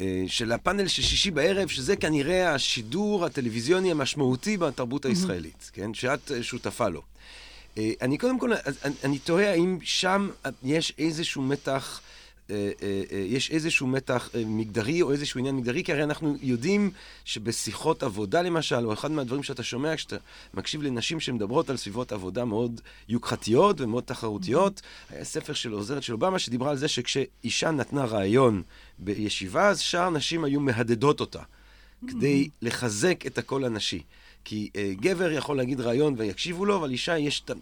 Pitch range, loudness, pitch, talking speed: 120-160 Hz, -27 LUFS, 135 Hz, 145 wpm